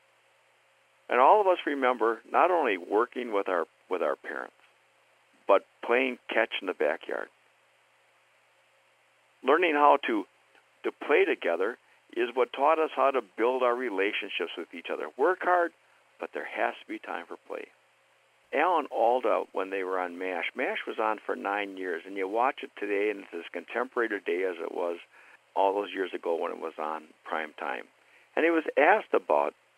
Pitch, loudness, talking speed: 125 Hz, -28 LUFS, 180 wpm